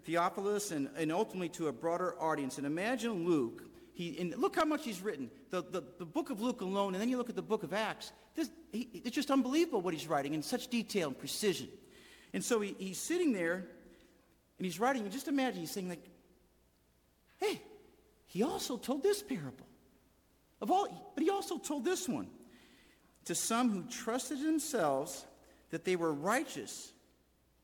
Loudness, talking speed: -36 LUFS, 185 wpm